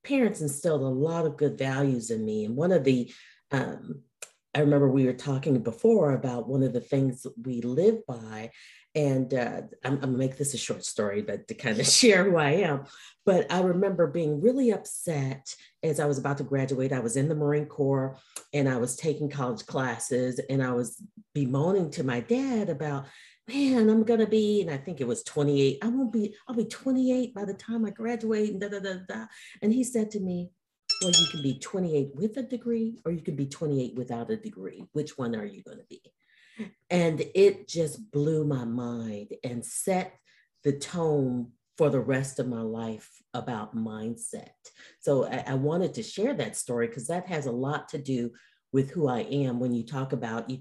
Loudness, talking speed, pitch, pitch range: -28 LUFS, 210 wpm, 145 Hz, 130-200 Hz